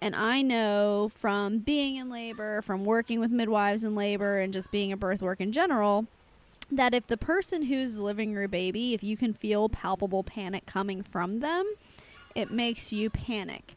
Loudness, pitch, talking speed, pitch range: -29 LUFS, 215 Hz, 185 wpm, 200-240 Hz